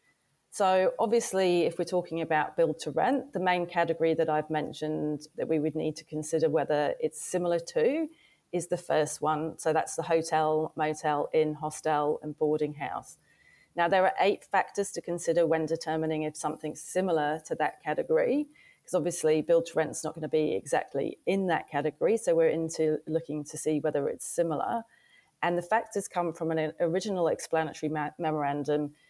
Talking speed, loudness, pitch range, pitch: 175 wpm, -29 LUFS, 155-175 Hz, 160 Hz